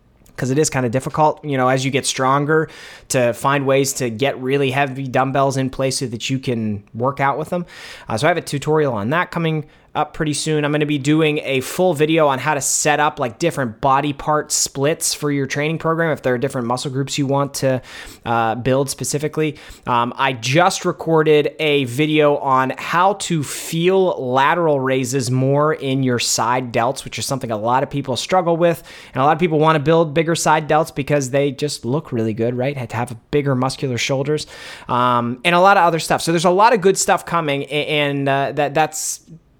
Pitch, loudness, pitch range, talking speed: 140 Hz, -18 LUFS, 130-155 Hz, 220 wpm